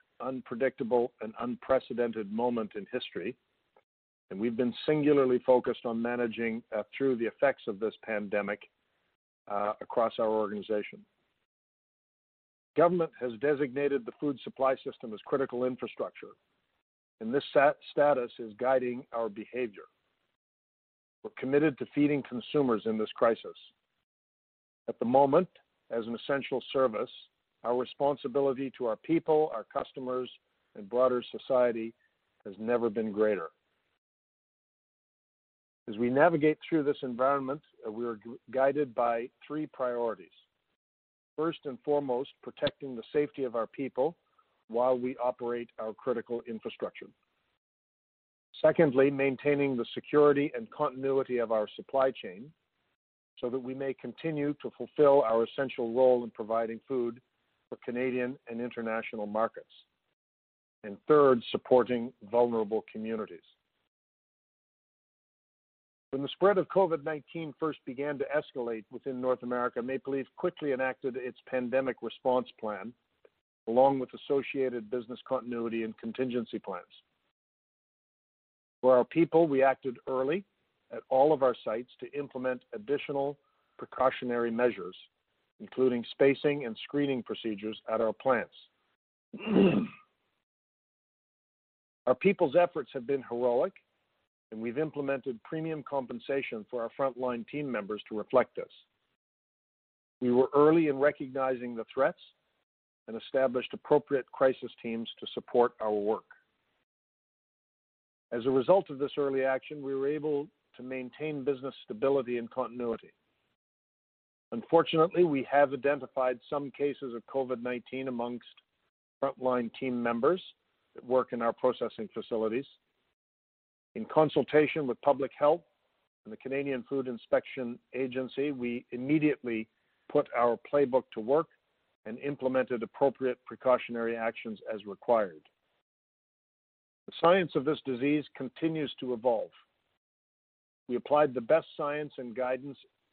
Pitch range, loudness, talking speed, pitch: 120-145 Hz, -31 LUFS, 125 wpm, 130 Hz